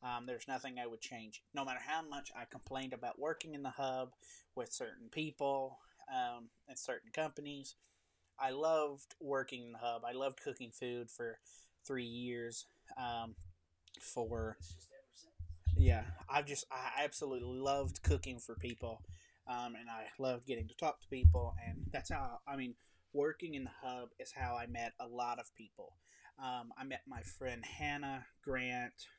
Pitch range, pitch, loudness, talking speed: 110-135 Hz, 120 Hz, -42 LUFS, 165 wpm